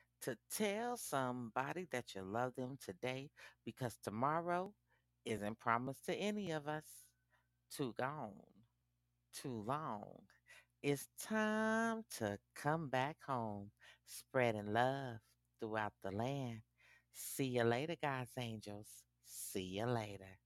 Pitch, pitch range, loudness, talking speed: 120 Hz, 105-140 Hz, -42 LUFS, 115 wpm